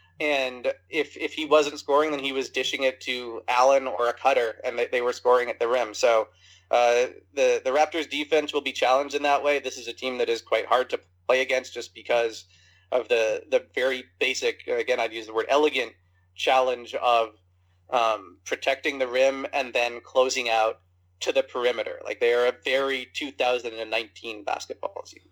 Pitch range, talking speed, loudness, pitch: 115-160 Hz, 190 wpm, -25 LUFS, 130 Hz